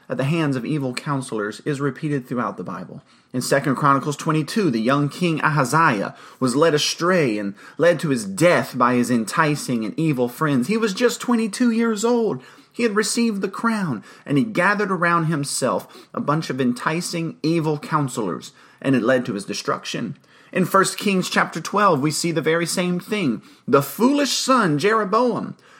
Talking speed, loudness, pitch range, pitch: 180 wpm, -21 LUFS, 140-210 Hz, 165 Hz